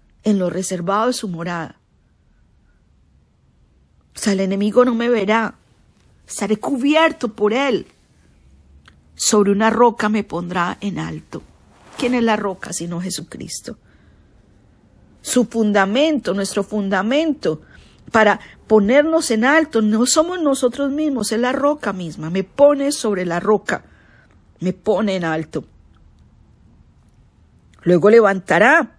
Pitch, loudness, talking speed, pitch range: 205 Hz, -18 LUFS, 120 wpm, 165-240 Hz